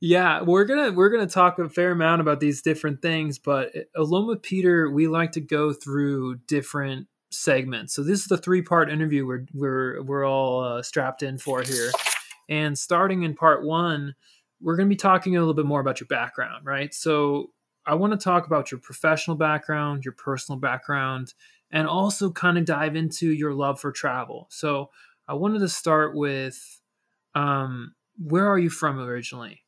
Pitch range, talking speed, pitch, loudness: 140-175 Hz, 190 wpm, 155 Hz, -24 LUFS